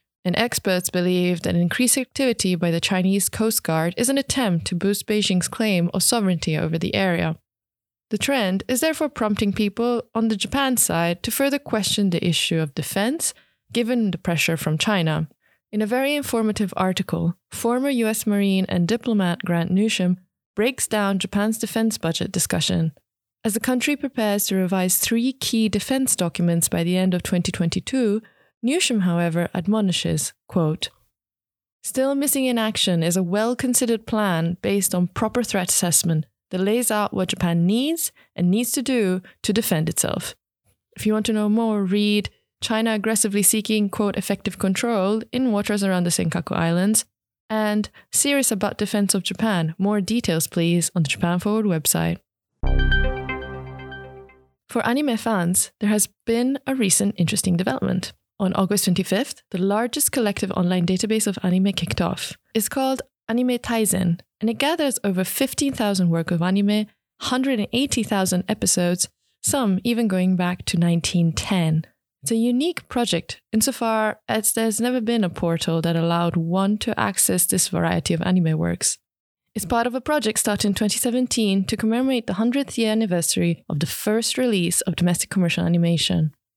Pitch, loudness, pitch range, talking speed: 200 Hz, -21 LUFS, 175-225 Hz, 155 wpm